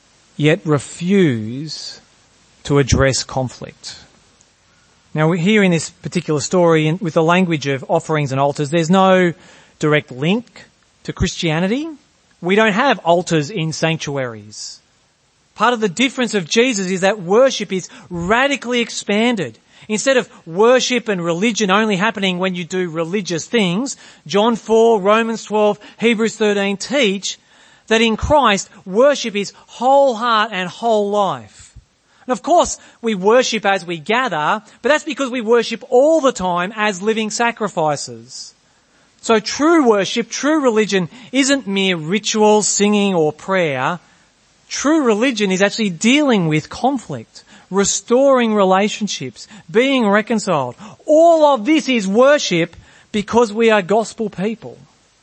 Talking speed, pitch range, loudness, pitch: 135 wpm, 175-235 Hz, -16 LUFS, 210 Hz